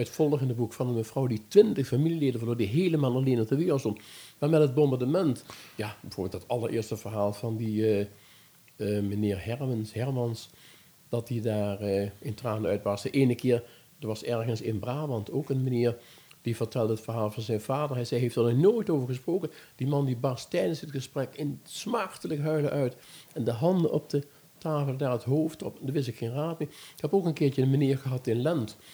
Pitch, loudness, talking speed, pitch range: 125 Hz, -29 LUFS, 215 wpm, 115-145 Hz